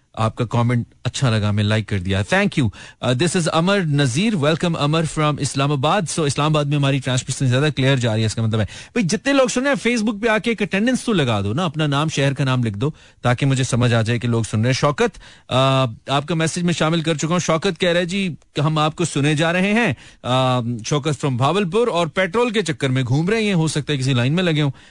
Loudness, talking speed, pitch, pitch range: -19 LUFS, 220 wpm, 150 Hz, 125-175 Hz